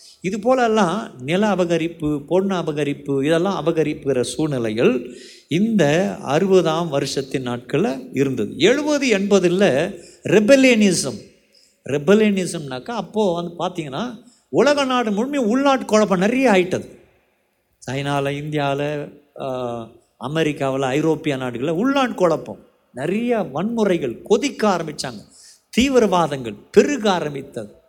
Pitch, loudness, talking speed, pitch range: 175 Hz, -19 LUFS, 90 wpm, 145-215 Hz